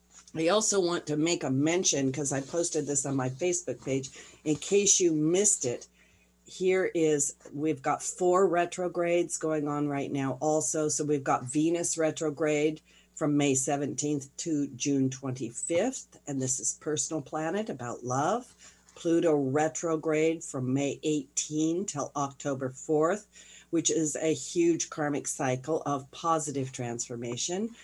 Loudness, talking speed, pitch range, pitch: -29 LUFS, 140 wpm, 140-165 Hz, 155 Hz